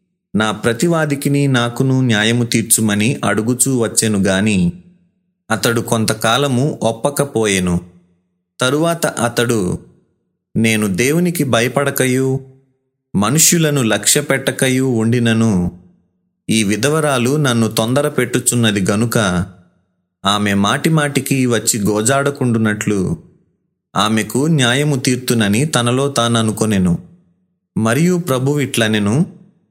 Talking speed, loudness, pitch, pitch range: 75 wpm, -15 LUFS, 125 Hz, 110-145 Hz